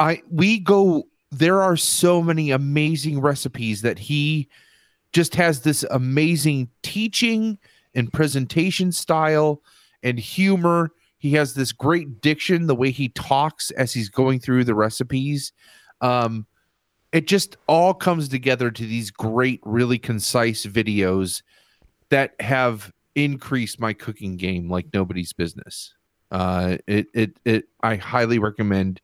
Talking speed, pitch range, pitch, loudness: 130 wpm, 115-155 Hz, 135 Hz, -21 LUFS